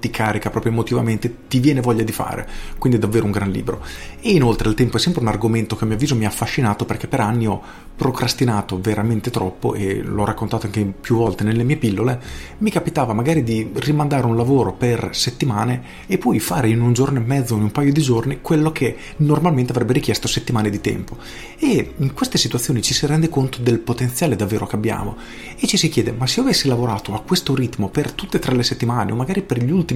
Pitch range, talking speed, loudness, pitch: 110-135 Hz, 220 wpm, -19 LUFS, 120 Hz